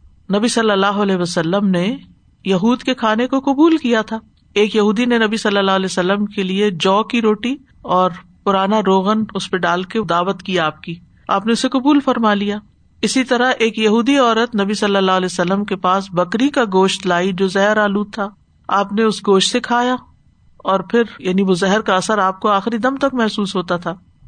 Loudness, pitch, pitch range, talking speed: -16 LUFS, 205 Hz, 190-225 Hz, 205 wpm